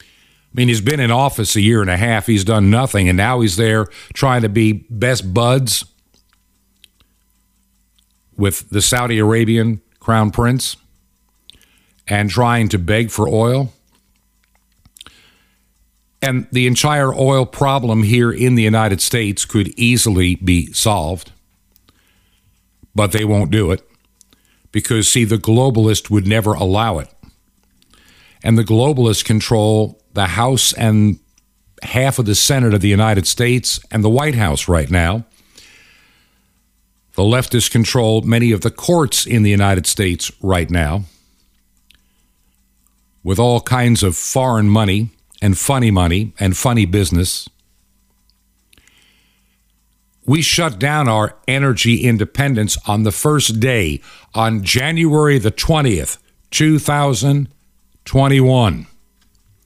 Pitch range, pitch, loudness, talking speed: 95-120 Hz, 110 Hz, -15 LUFS, 125 wpm